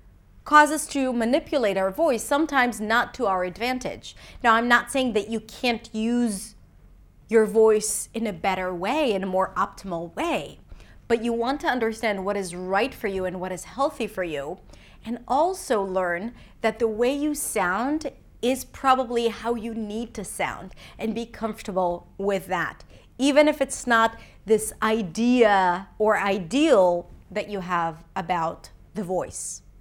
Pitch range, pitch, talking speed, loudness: 195-245 Hz, 225 Hz, 160 wpm, -24 LUFS